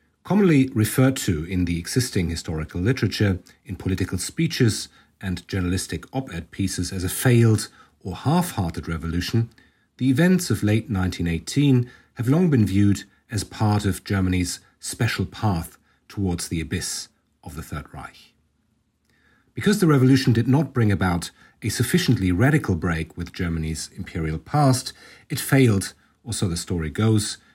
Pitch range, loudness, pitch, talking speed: 90-130 Hz, -23 LUFS, 100 Hz, 140 wpm